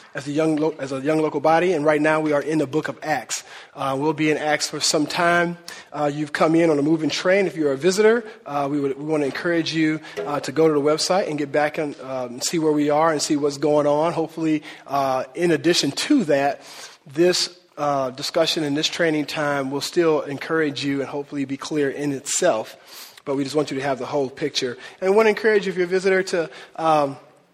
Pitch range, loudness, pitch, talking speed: 145-165 Hz, -21 LUFS, 150 Hz, 240 wpm